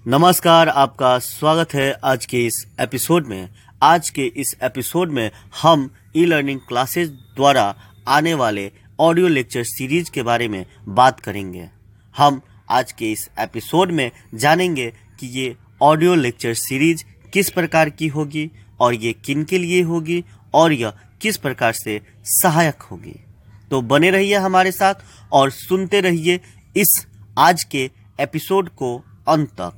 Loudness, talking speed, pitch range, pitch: -18 LUFS, 145 wpm, 110-165 Hz, 135 Hz